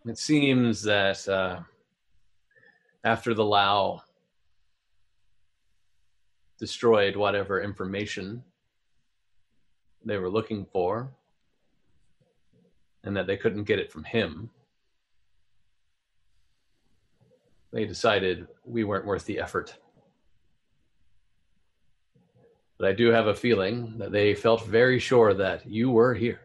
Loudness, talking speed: -25 LUFS, 100 wpm